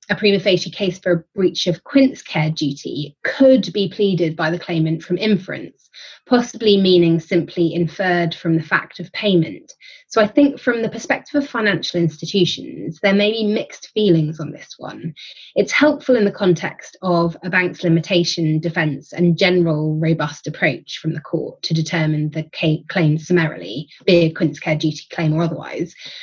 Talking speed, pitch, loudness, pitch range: 175 wpm, 175 Hz, -18 LUFS, 160-200 Hz